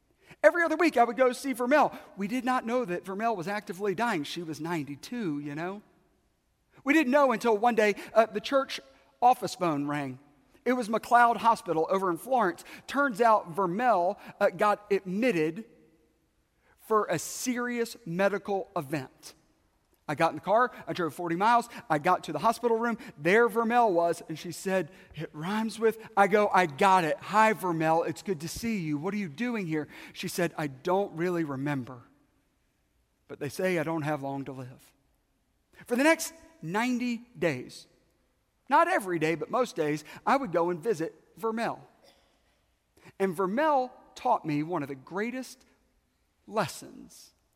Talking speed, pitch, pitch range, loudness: 170 wpm, 200 Hz, 165-235 Hz, -28 LUFS